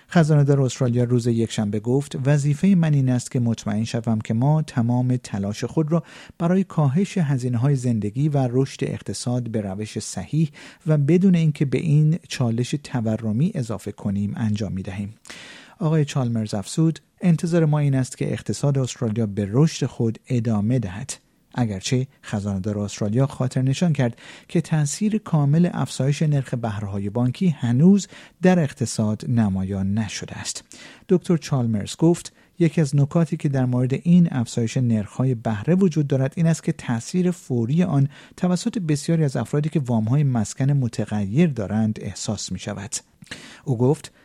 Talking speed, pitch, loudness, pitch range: 150 wpm, 130 Hz, -22 LUFS, 115-155 Hz